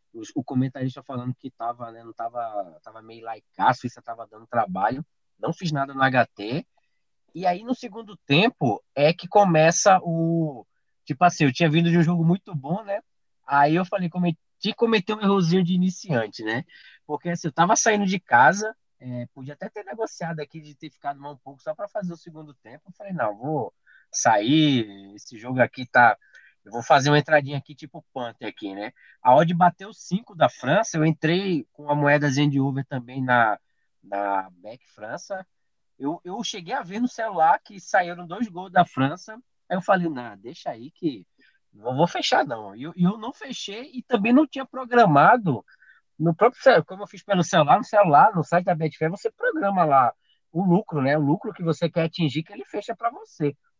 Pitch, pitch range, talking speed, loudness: 165 Hz, 140-195 Hz, 200 wpm, -22 LUFS